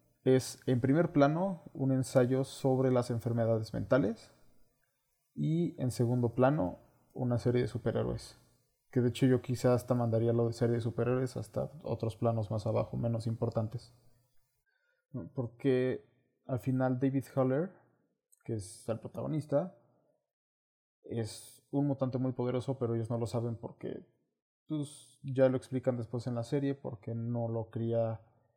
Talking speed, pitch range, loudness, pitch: 145 wpm, 115-130 Hz, -33 LUFS, 125 Hz